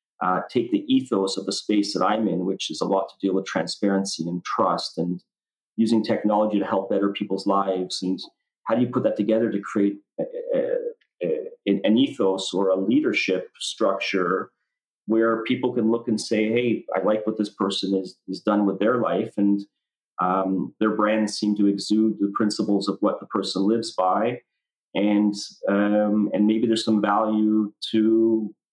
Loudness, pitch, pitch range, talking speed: -23 LUFS, 105 Hz, 100-110 Hz, 185 wpm